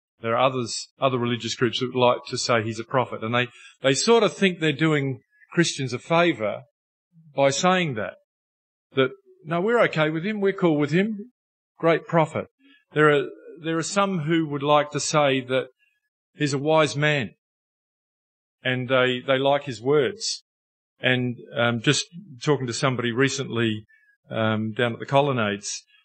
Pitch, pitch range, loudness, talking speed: 145 Hz, 125-170 Hz, -23 LUFS, 170 wpm